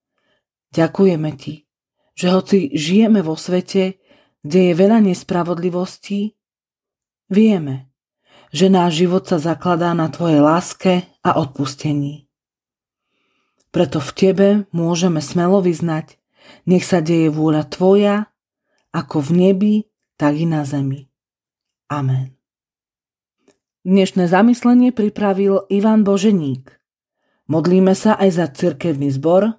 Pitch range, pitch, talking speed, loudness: 155-195 Hz, 180 Hz, 105 wpm, -16 LUFS